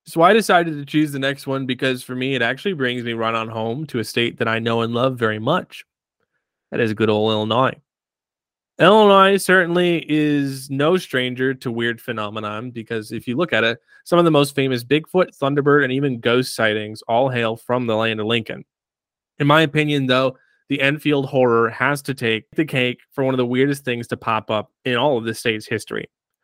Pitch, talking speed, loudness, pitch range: 130 Hz, 210 wpm, -19 LUFS, 115-145 Hz